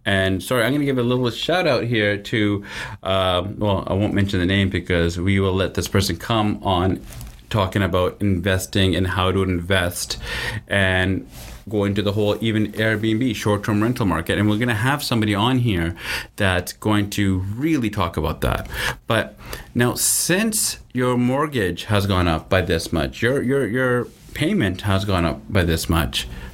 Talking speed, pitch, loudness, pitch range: 180 wpm, 100 Hz, -21 LUFS, 95-115 Hz